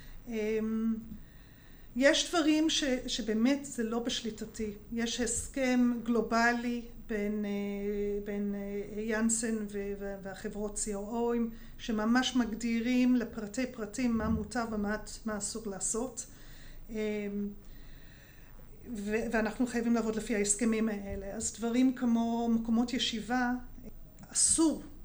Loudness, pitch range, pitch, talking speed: -32 LUFS, 210-240 Hz, 225 Hz, 100 wpm